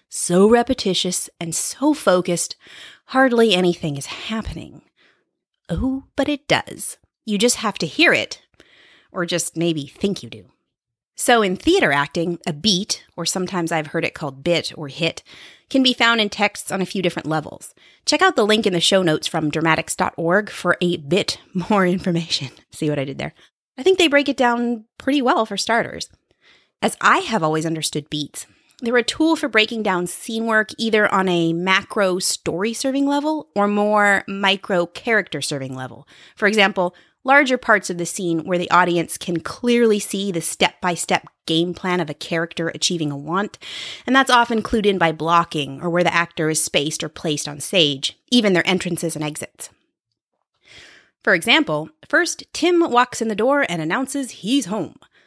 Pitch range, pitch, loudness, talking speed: 165-230 Hz, 185 Hz, -19 LUFS, 180 wpm